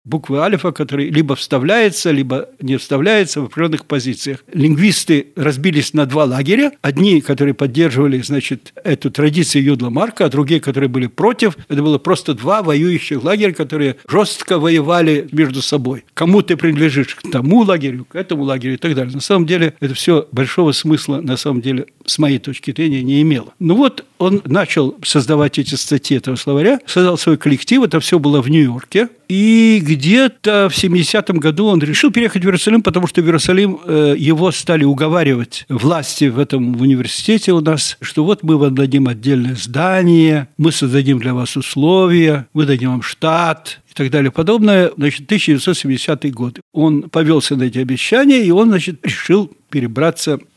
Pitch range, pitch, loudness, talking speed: 140-180 Hz, 155 Hz, -14 LUFS, 165 wpm